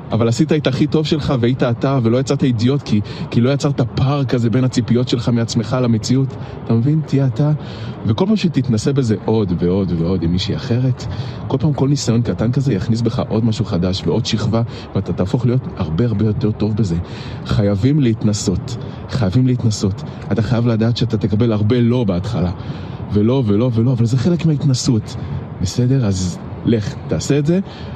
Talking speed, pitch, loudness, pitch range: 175 wpm, 120 Hz, -17 LUFS, 110-135 Hz